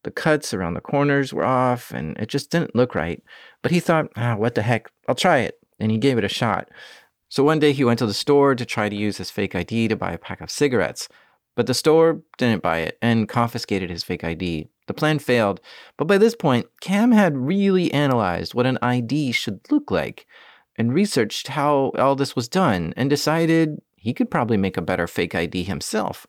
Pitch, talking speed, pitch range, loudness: 125 Hz, 220 wpm, 110-150 Hz, -21 LUFS